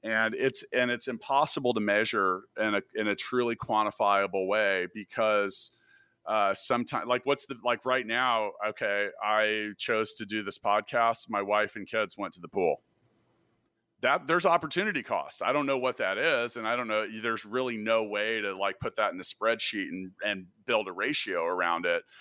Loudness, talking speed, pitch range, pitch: -29 LUFS, 190 wpm, 105-125 Hz, 110 Hz